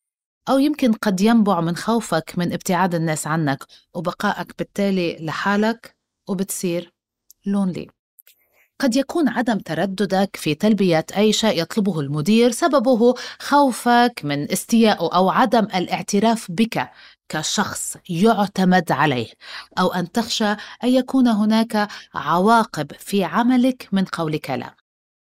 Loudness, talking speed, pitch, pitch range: -20 LUFS, 115 wpm, 200 Hz, 170-230 Hz